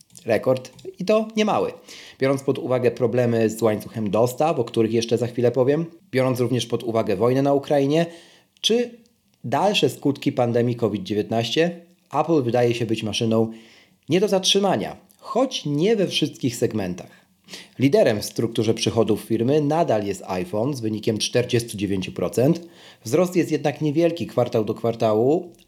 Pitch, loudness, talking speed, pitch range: 125 Hz, -22 LUFS, 145 wpm, 115-165 Hz